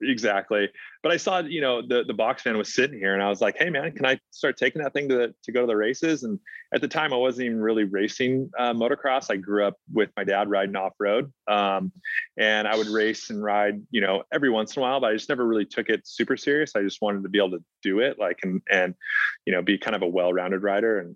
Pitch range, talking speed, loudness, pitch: 100-130 Hz, 270 wpm, -25 LUFS, 105 Hz